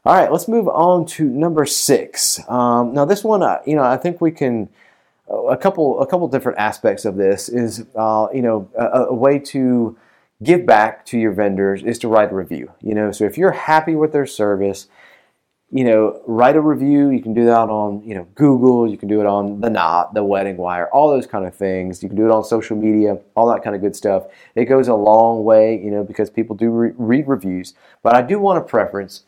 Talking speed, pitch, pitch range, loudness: 235 wpm, 115 Hz, 105-135 Hz, -16 LUFS